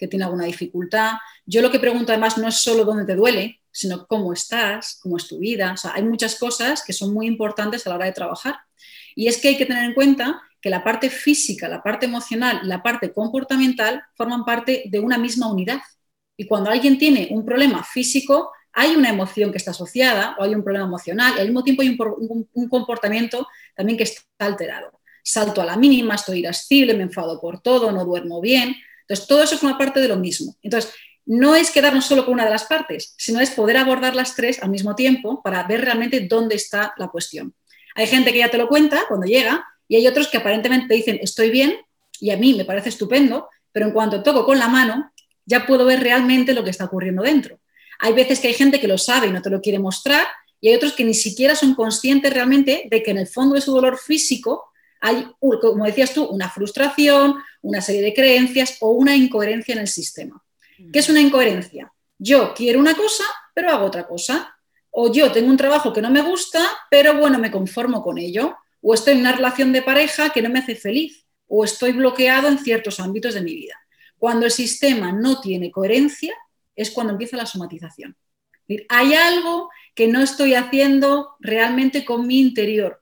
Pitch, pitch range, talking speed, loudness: 240 Hz, 210-270 Hz, 215 wpm, -18 LUFS